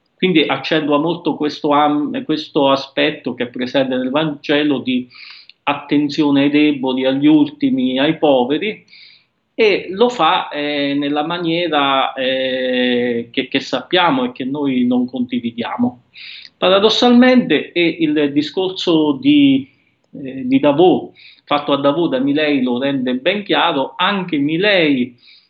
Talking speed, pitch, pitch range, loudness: 125 wpm, 150 Hz, 135-195 Hz, -16 LUFS